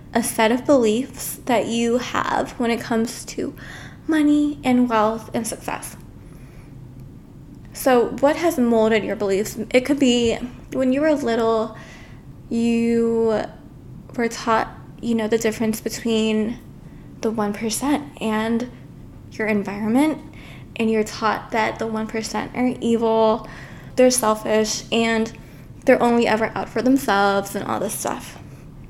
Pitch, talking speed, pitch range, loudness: 230 Hz, 130 wpm, 220-245 Hz, -21 LUFS